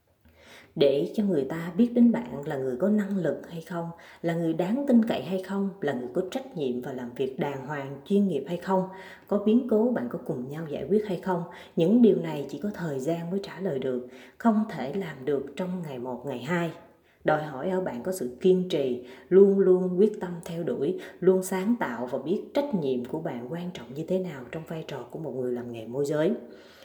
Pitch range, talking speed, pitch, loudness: 145-195 Hz, 230 wpm, 180 Hz, -27 LUFS